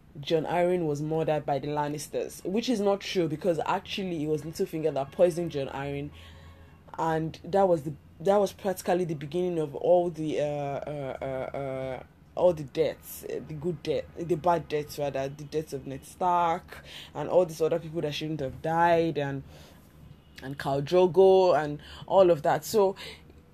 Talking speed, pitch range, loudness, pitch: 175 wpm, 145-175 Hz, -28 LUFS, 160 Hz